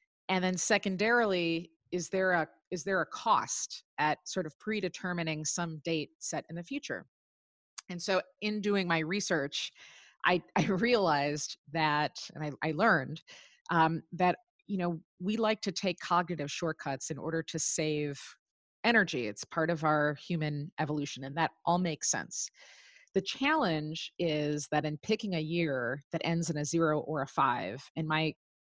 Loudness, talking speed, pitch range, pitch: -32 LUFS, 165 wpm, 155-190 Hz, 170 Hz